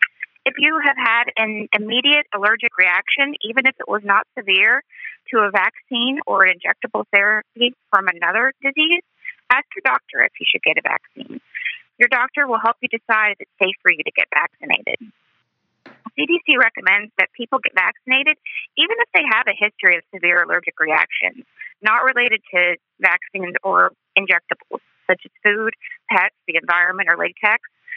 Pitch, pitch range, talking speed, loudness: 225 Hz, 200-265 Hz, 165 wpm, -17 LUFS